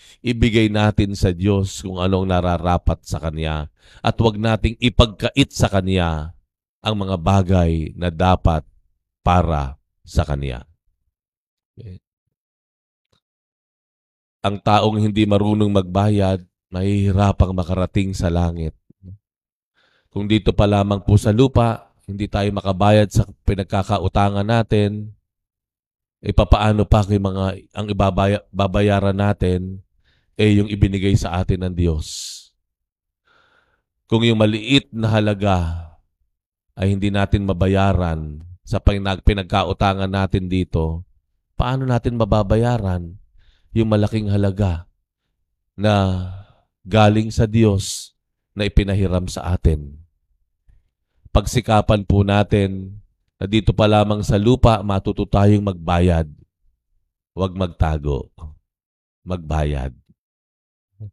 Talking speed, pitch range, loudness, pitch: 105 wpm, 90-105 Hz, -19 LUFS, 100 Hz